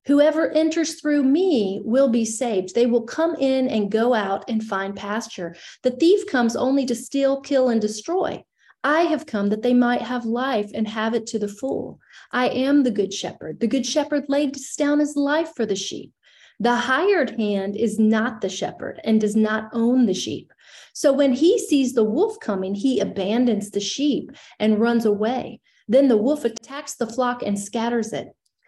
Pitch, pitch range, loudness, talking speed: 245 Hz, 215-280 Hz, -21 LUFS, 190 wpm